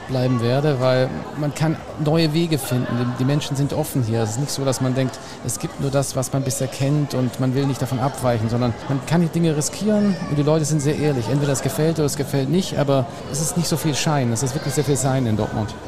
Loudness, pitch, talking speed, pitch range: -21 LUFS, 140 Hz, 255 wpm, 130-150 Hz